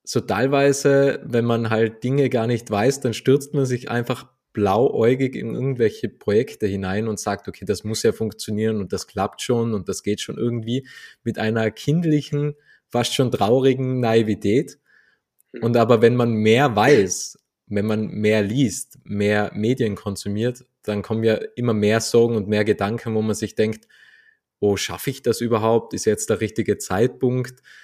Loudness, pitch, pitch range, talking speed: -21 LUFS, 115 Hz, 110-130 Hz, 170 wpm